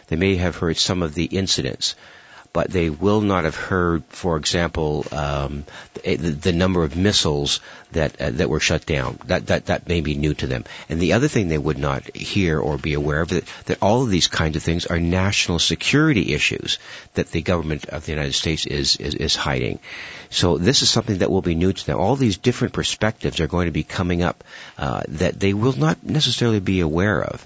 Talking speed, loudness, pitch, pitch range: 220 wpm, -21 LUFS, 85 Hz, 80-100 Hz